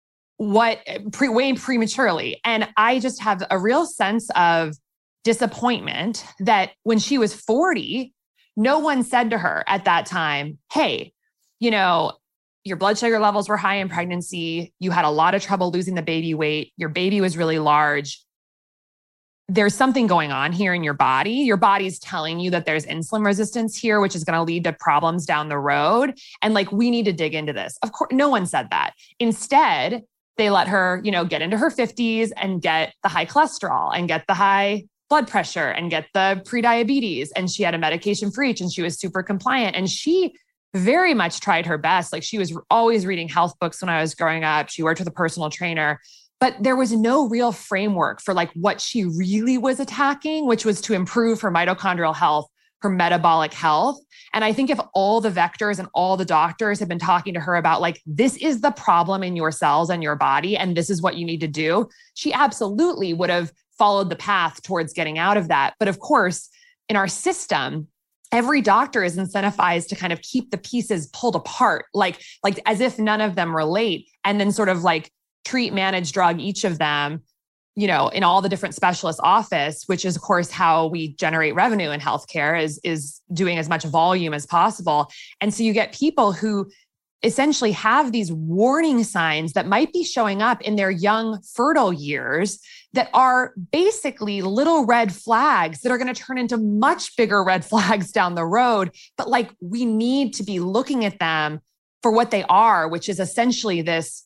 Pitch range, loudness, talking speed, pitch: 170-230 Hz, -21 LUFS, 200 wpm, 195 Hz